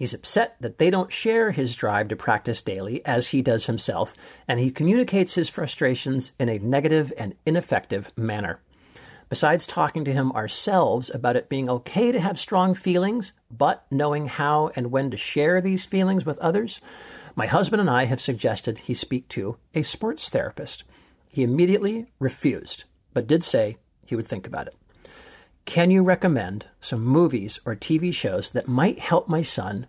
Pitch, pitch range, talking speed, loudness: 145 Hz, 125-180 Hz, 175 wpm, -23 LUFS